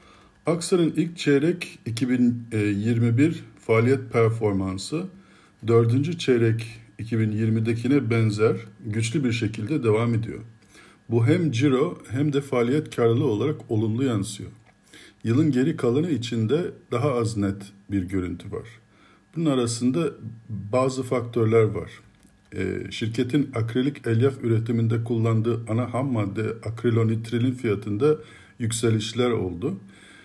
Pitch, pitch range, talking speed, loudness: 115 Hz, 110-130 Hz, 105 wpm, -24 LUFS